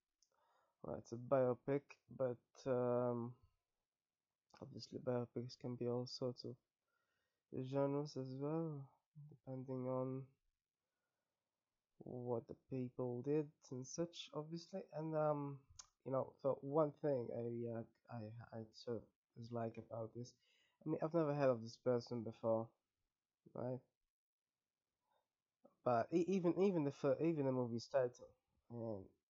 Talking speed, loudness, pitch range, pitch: 125 wpm, -44 LUFS, 120-145 Hz, 130 Hz